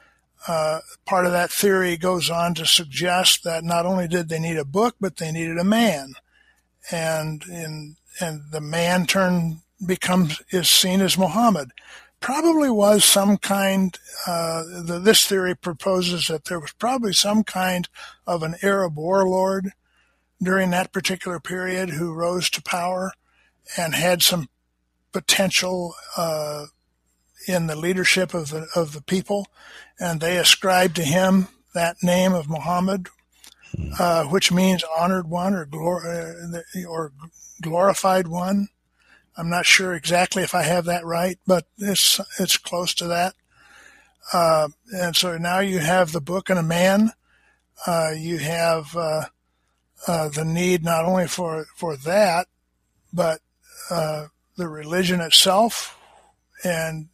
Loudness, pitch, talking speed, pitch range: -21 LUFS, 175 Hz, 145 wpm, 165-185 Hz